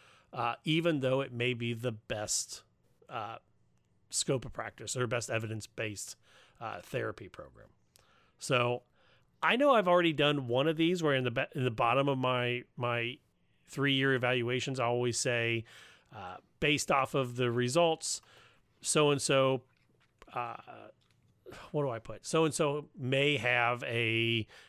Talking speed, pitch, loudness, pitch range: 150 wpm, 125 Hz, -31 LUFS, 115-140 Hz